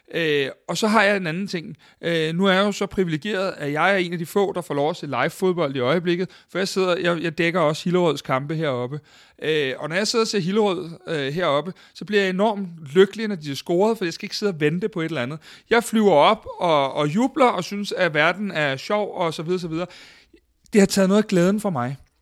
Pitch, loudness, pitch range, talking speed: 180 Hz, -22 LUFS, 160-200 Hz, 260 wpm